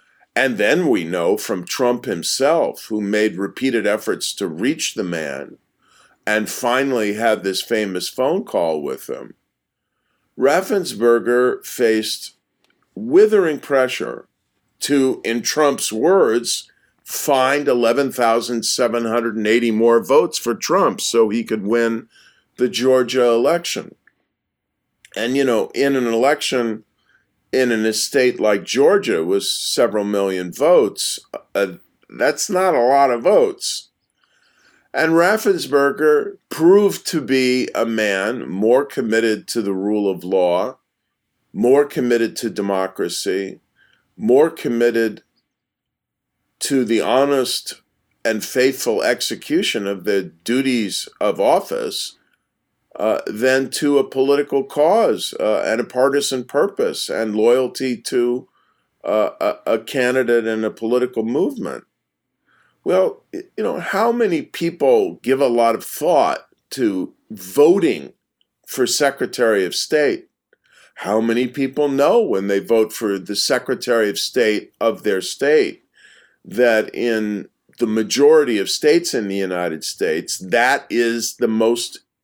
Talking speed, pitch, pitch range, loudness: 120 wpm, 125 Hz, 110-170 Hz, -18 LUFS